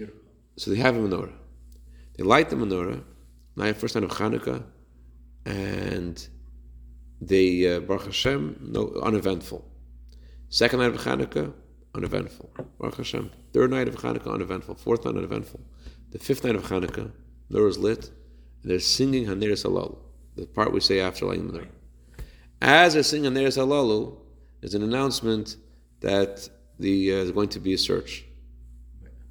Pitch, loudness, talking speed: 85 Hz, -25 LUFS, 150 wpm